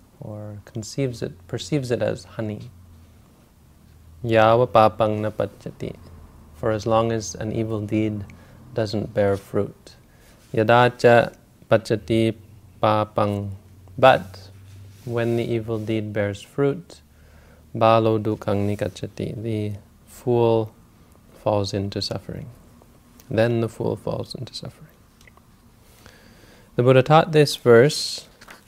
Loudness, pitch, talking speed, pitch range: -21 LUFS, 110 Hz, 100 wpm, 100-115 Hz